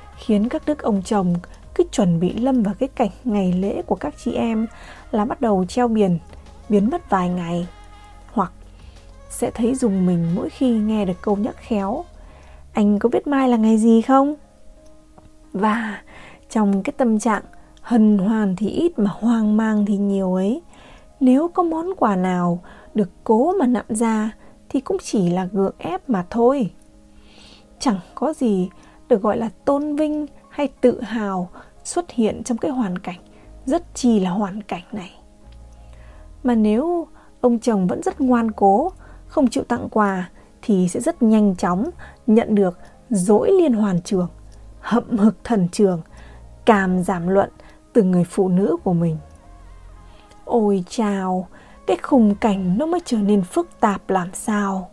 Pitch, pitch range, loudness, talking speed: 210 Hz, 185-240 Hz, -20 LUFS, 165 wpm